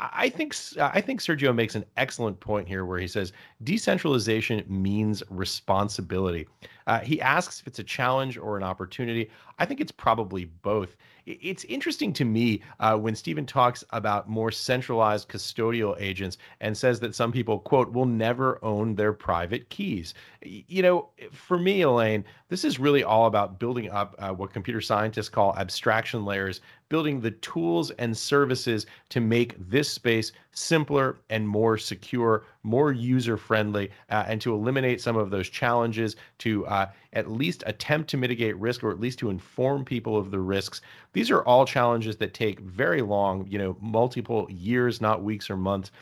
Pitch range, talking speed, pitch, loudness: 105-125 Hz, 170 wpm, 110 Hz, -26 LUFS